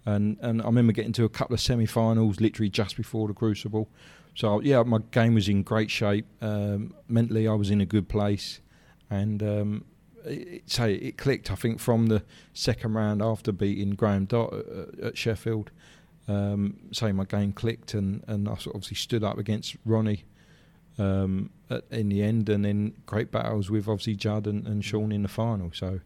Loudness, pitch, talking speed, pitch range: -27 LUFS, 110 Hz, 190 wpm, 105-115 Hz